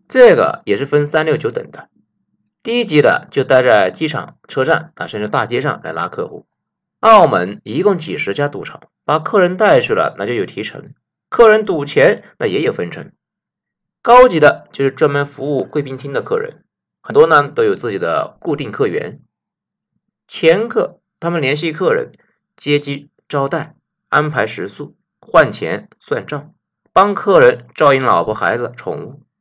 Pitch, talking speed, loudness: 165 Hz, 240 characters per minute, -14 LUFS